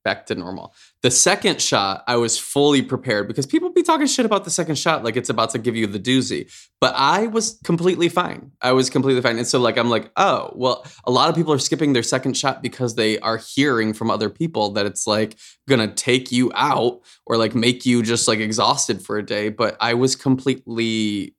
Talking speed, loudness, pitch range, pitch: 225 wpm, -19 LUFS, 115-145 Hz, 125 Hz